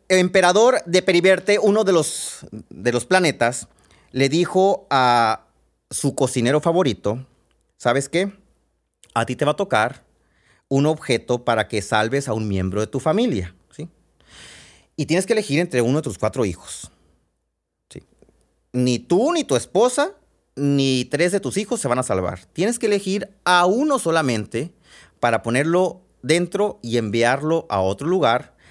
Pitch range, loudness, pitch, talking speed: 115-180 Hz, -20 LUFS, 140 Hz, 155 wpm